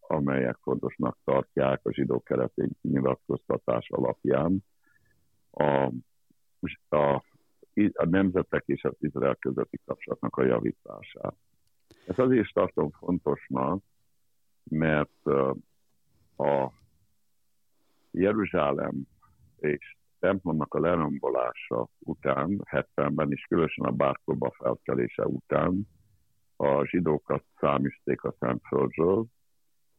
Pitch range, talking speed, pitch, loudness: 70-95 Hz, 90 wpm, 75 Hz, -28 LUFS